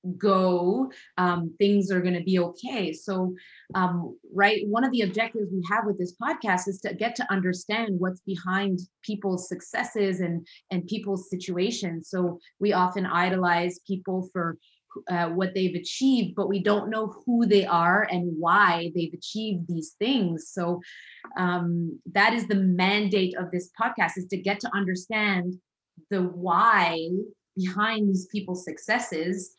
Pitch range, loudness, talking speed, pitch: 180-205 Hz, -26 LUFS, 155 wpm, 185 Hz